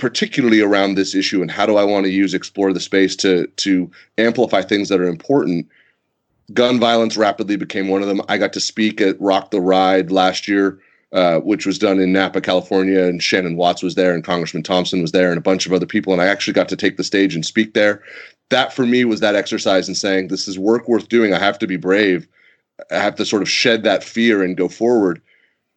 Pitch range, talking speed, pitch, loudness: 95-105 Hz, 235 wpm, 95 Hz, -16 LUFS